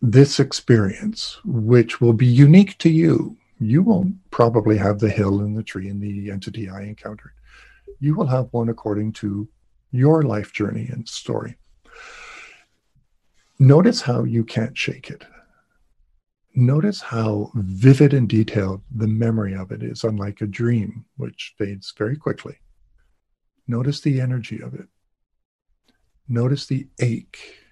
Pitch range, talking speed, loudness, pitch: 105-135 Hz, 140 wpm, -19 LUFS, 115 Hz